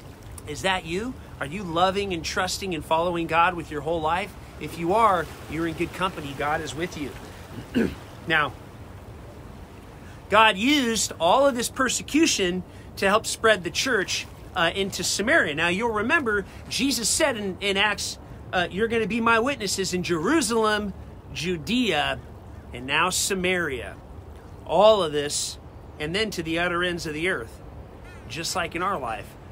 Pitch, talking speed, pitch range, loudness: 180 Hz, 160 wpm, 160-215 Hz, -24 LUFS